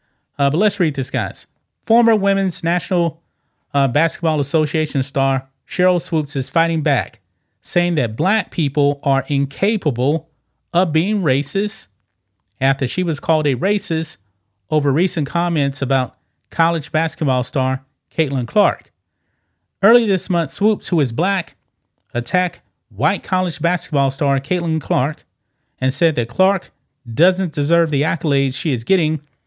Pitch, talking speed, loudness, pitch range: 155 Hz, 135 wpm, -18 LUFS, 135-175 Hz